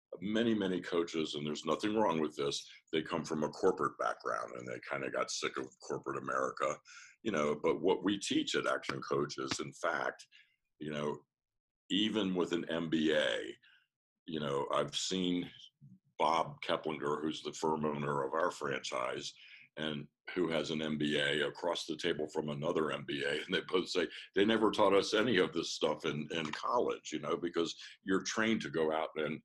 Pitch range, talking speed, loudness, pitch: 75-90 Hz, 180 wpm, -35 LUFS, 80 Hz